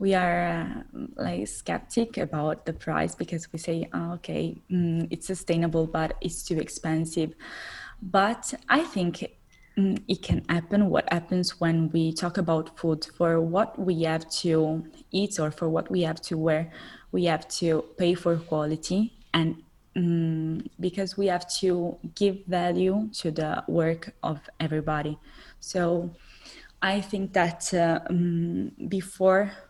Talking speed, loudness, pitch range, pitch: 145 wpm, -27 LUFS, 160-190 Hz, 175 Hz